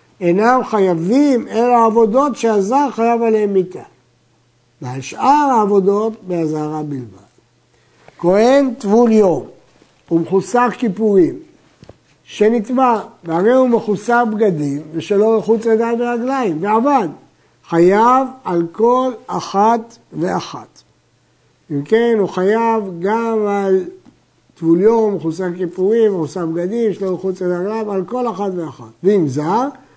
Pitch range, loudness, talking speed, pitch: 175-235 Hz, -15 LUFS, 110 wpm, 210 Hz